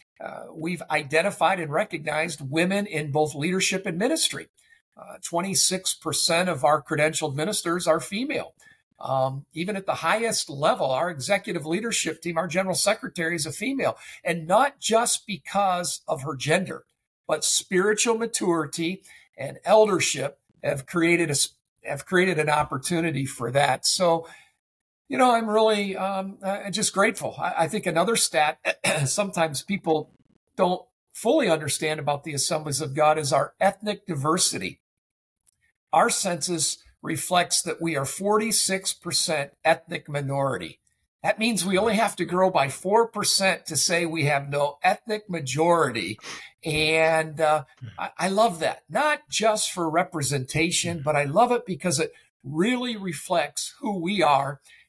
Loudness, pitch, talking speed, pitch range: -23 LUFS, 170 Hz, 145 wpm, 155-195 Hz